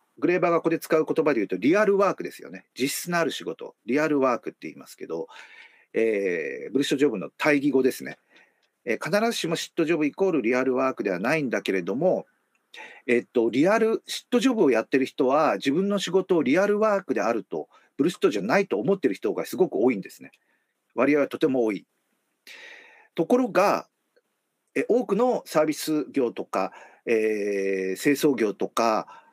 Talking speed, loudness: 400 characters per minute, -24 LUFS